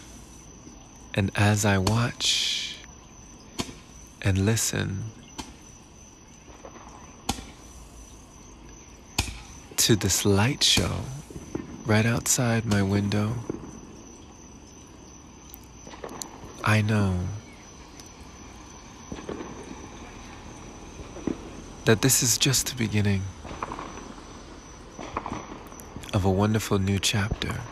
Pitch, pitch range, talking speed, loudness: 105 Hz, 95-115 Hz, 60 wpm, -25 LUFS